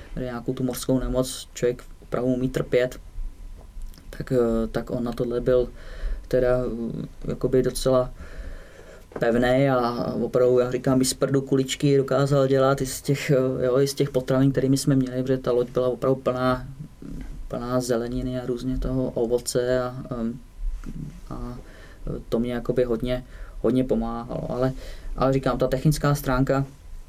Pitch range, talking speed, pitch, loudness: 120-130 Hz, 140 wpm, 125 Hz, -24 LUFS